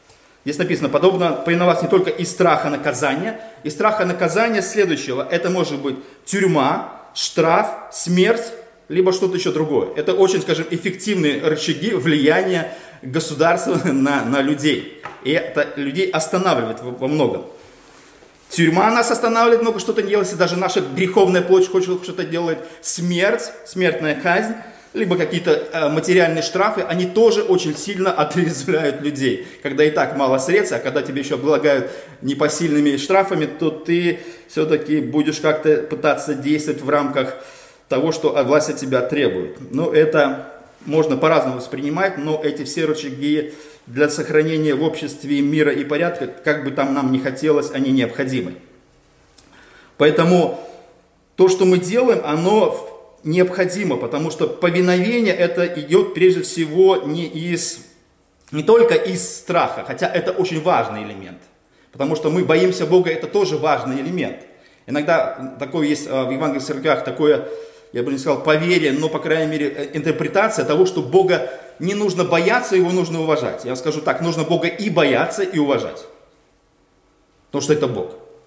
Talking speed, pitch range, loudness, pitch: 145 wpm, 150-185 Hz, -18 LUFS, 165 Hz